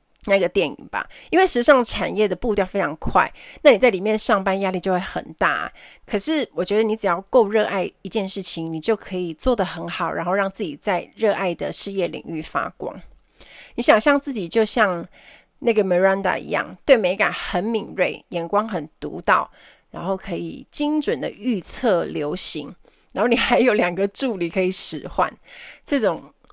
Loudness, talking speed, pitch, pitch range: -20 LUFS, 280 characters per minute, 195 Hz, 180-225 Hz